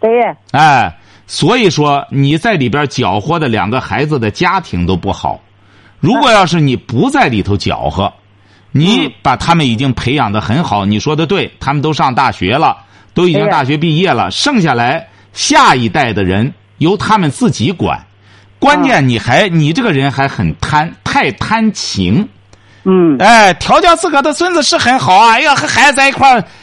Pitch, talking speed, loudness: 145 Hz, 255 characters per minute, -11 LUFS